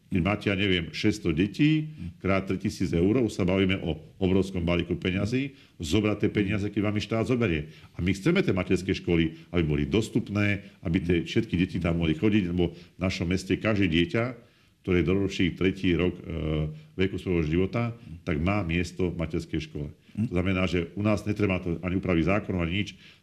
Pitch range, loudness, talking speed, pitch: 85-105 Hz, -27 LUFS, 185 wpm, 95 Hz